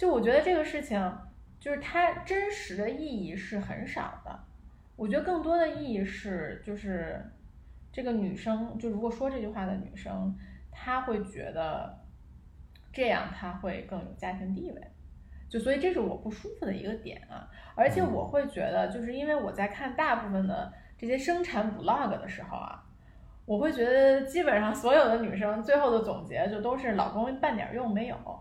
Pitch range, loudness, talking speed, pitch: 195-275 Hz, -30 LUFS, 270 characters per minute, 220 Hz